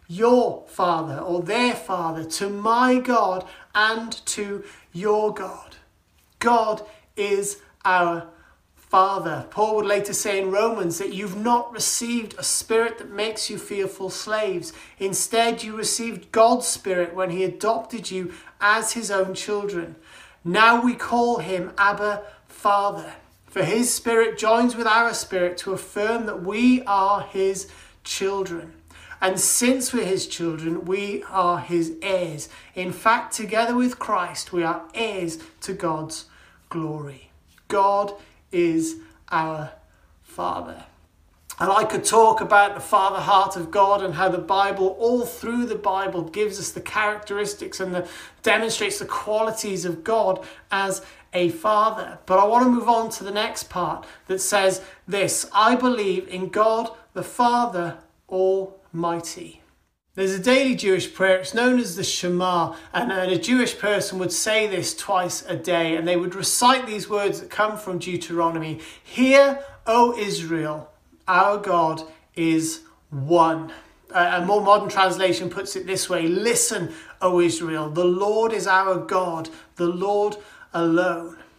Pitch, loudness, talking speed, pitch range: 195 Hz, -22 LUFS, 150 wpm, 175-220 Hz